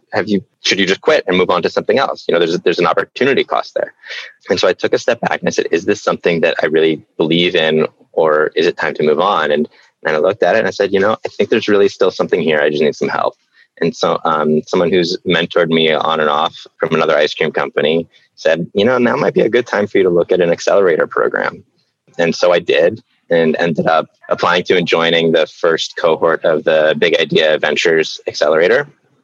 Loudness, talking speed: -14 LUFS, 245 wpm